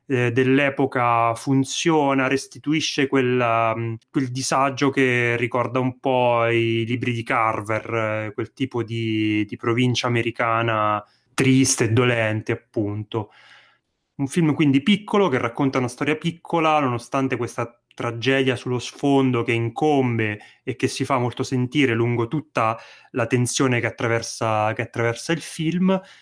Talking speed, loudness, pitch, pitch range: 130 wpm, -21 LUFS, 125 Hz, 115-135 Hz